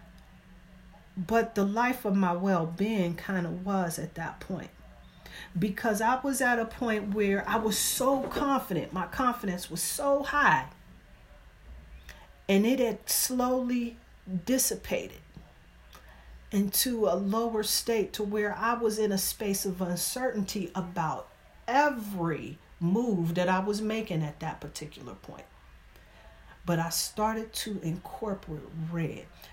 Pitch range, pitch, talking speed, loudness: 165-225 Hz, 200 Hz, 130 wpm, -29 LUFS